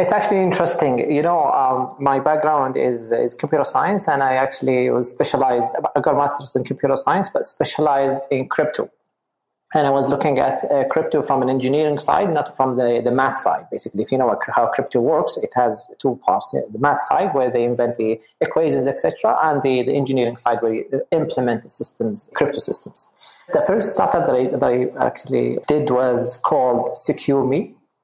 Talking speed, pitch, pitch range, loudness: 190 wpm, 135 Hz, 125-150 Hz, -19 LUFS